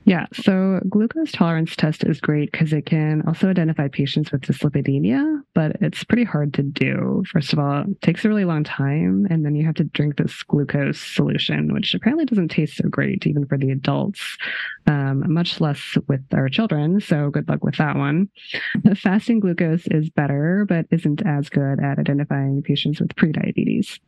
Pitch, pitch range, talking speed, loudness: 160 Hz, 145-195 Hz, 185 wpm, -20 LUFS